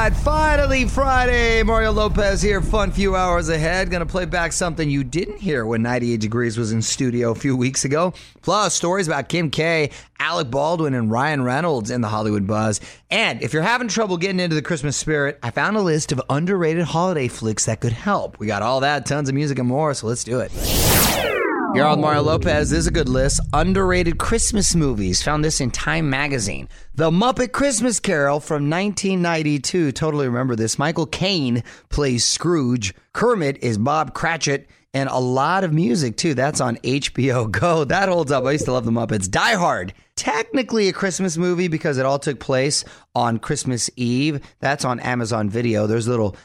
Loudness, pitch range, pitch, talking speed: -20 LUFS, 125-180 Hz, 150 Hz, 190 wpm